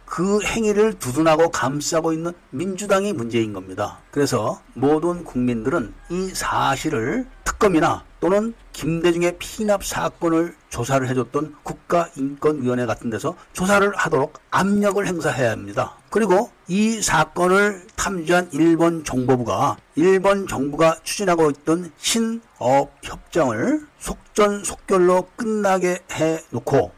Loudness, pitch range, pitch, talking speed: -21 LUFS, 140-195 Hz, 165 Hz, 285 characters per minute